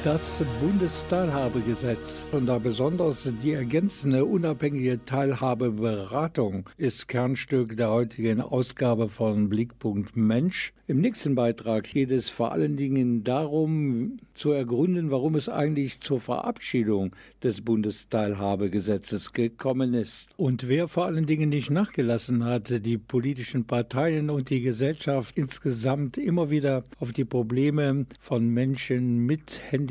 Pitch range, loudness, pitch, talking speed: 120-145 Hz, -27 LUFS, 130 Hz, 120 wpm